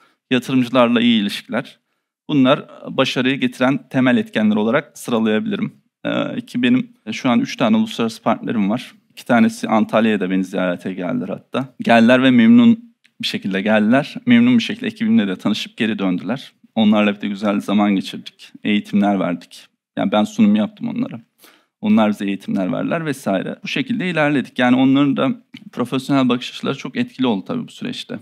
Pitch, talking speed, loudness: 145 Hz, 155 wpm, -18 LUFS